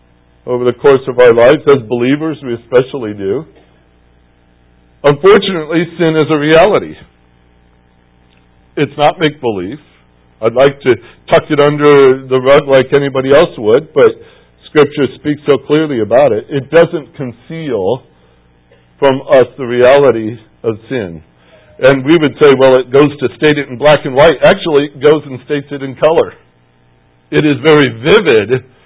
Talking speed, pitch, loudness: 155 wpm, 135 Hz, -10 LUFS